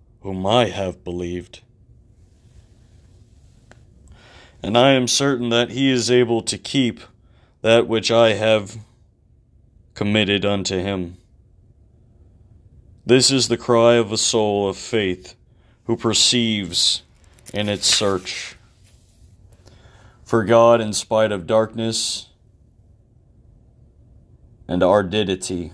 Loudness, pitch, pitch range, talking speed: -18 LUFS, 105 Hz, 95-115 Hz, 100 wpm